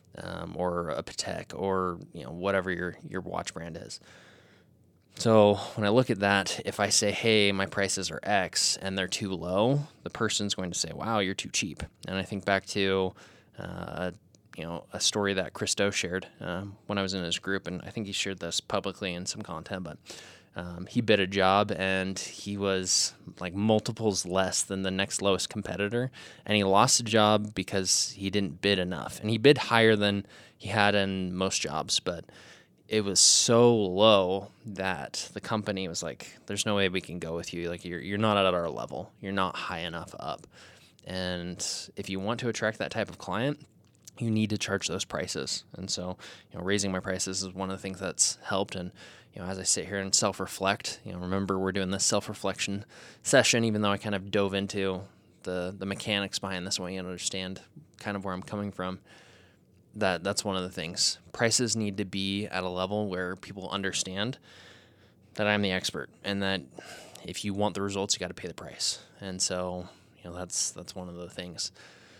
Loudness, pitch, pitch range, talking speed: -28 LUFS, 95 Hz, 95-105 Hz, 205 wpm